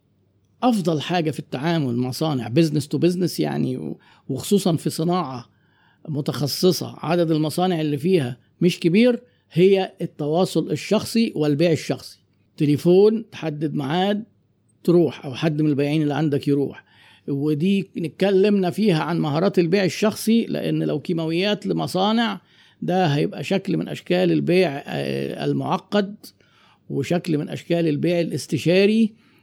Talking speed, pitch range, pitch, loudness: 120 wpm, 145-185 Hz, 165 Hz, -21 LUFS